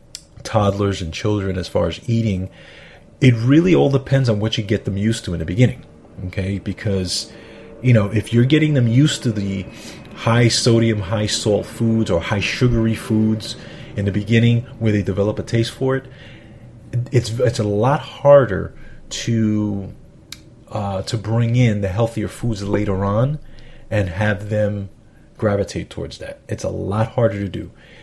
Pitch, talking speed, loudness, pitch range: 110 Hz, 165 wpm, -19 LUFS, 100-120 Hz